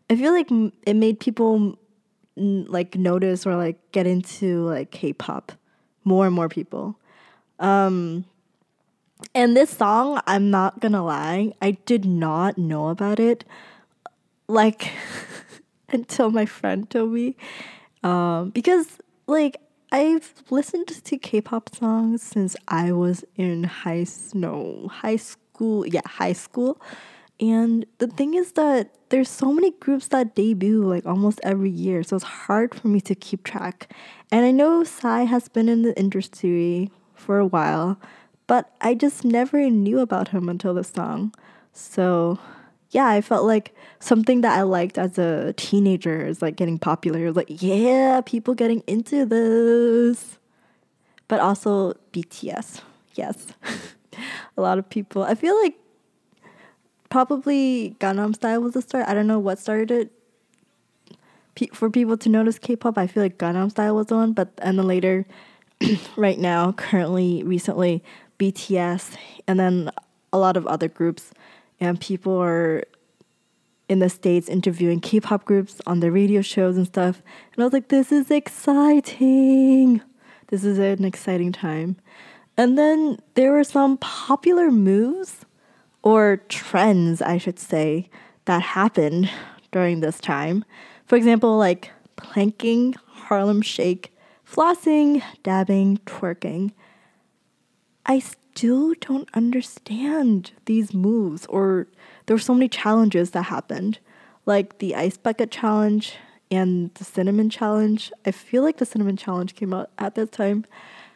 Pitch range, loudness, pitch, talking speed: 185-240 Hz, -21 LUFS, 210 Hz, 140 wpm